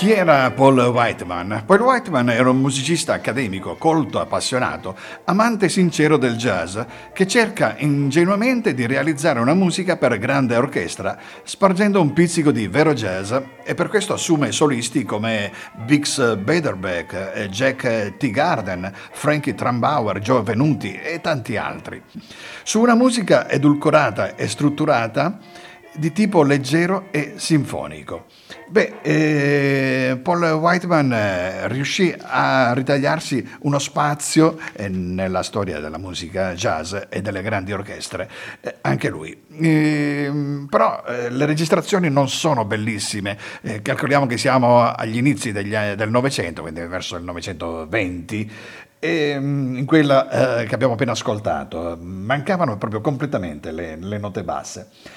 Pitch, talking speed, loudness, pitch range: 135 Hz, 135 wpm, -19 LUFS, 110-155 Hz